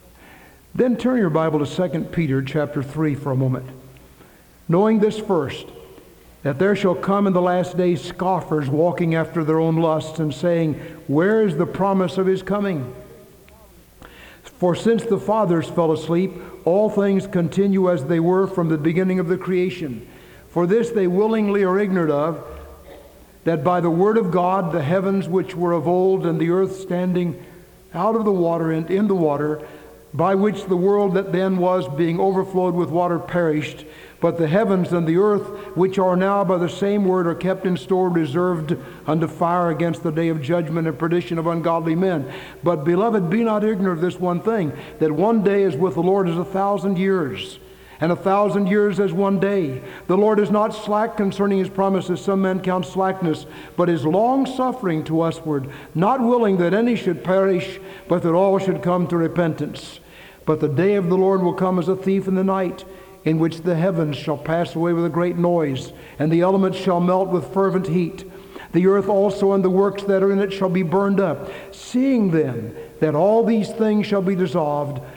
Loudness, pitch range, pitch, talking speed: -20 LUFS, 165-195 Hz, 180 Hz, 195 wpm